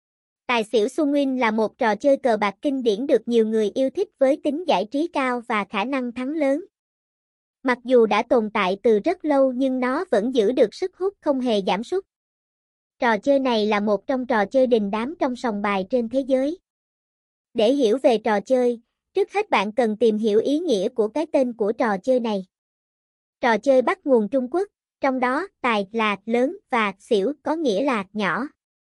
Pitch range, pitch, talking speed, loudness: 220-285 Hz, 255 Hz, 205 wpm, -22 LUFS